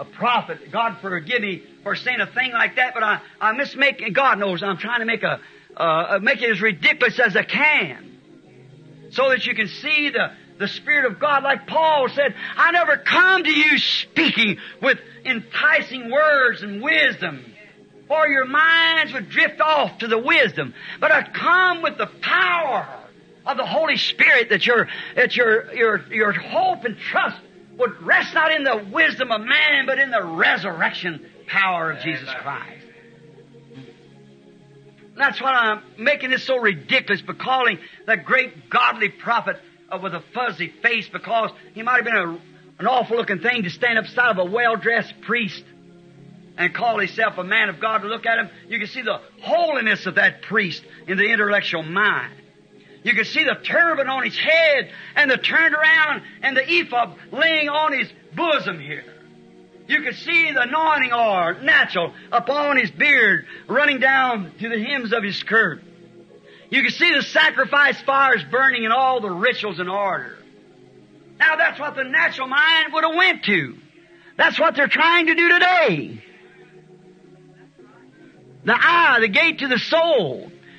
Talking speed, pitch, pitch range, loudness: 170 wpm, 250 Hz, 205-300 Hz, -18 LUFS